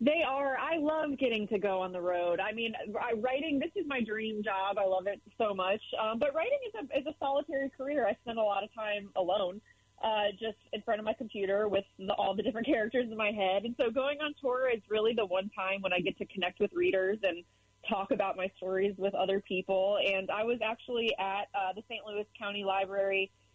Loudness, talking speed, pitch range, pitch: -33 LUFS, 230 wpm, 195-250 Hz, 210 Hz